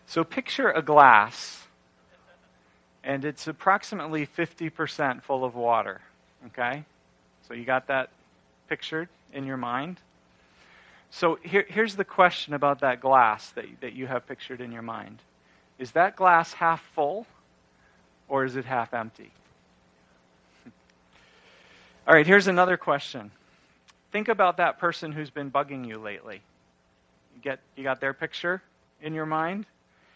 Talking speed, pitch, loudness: 135 wpm, 130 Hz, -25 LUFS